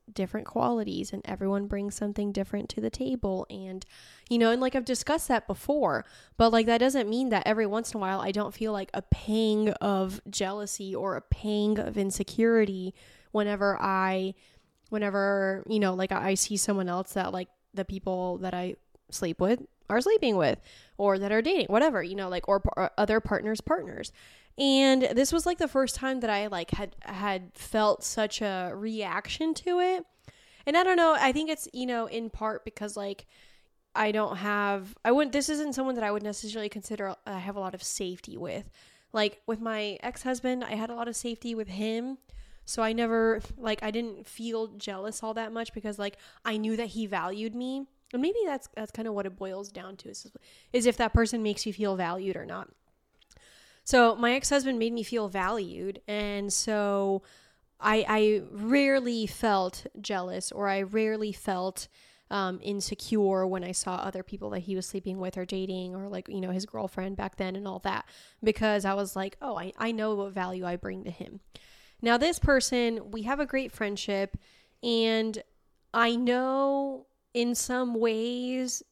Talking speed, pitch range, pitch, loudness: 190 wpm, 195-235 Hz, 215 Hz, -29 LUFS